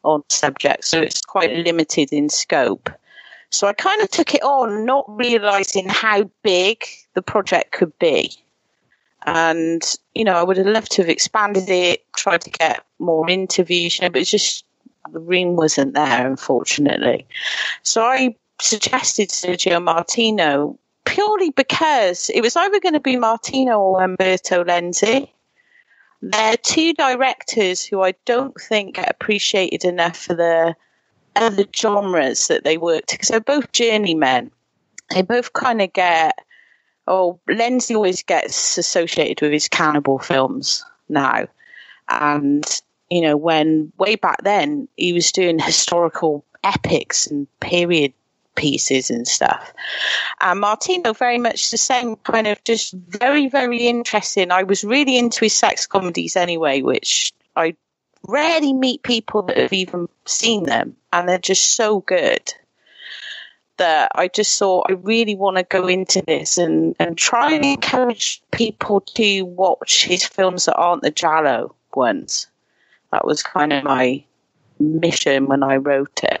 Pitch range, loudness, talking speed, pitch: 170-240 Hz, -17 LUFS, 150 wpm, 195 Hz